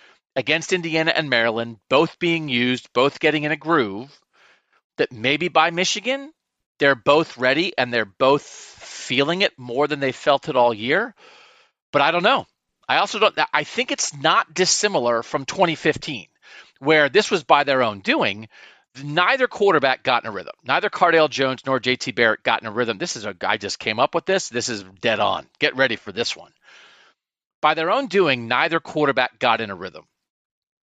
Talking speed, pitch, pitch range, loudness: 185 wpm, 150 Hz, 125-175 Hz, -20 LUFS